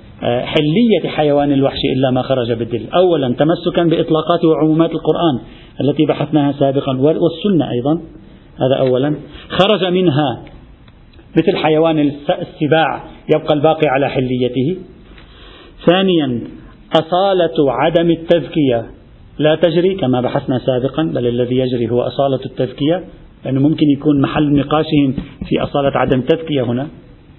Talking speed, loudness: 115 wpm, -15 LUFS